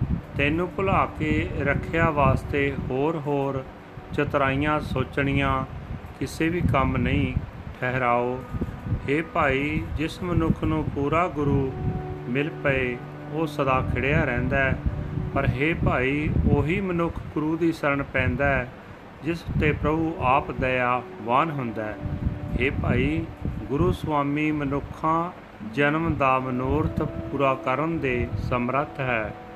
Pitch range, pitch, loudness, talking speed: 130-155 Hz, 140 Hz, -25 LUFS, 115 wpm